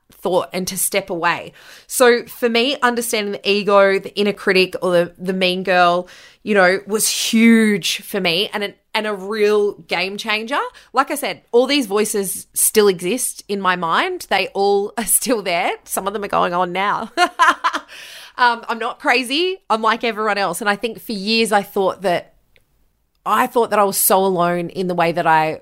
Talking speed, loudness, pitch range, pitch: 195 wpm, -17 LUFS, 185-230 Hz, 205 Hz